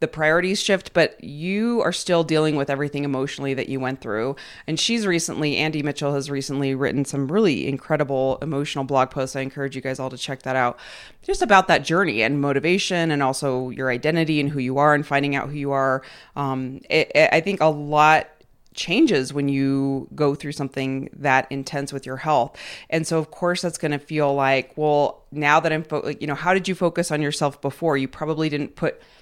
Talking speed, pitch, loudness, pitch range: 215 wpm, 145 Hz, -22 LUFS, 135-155 Hz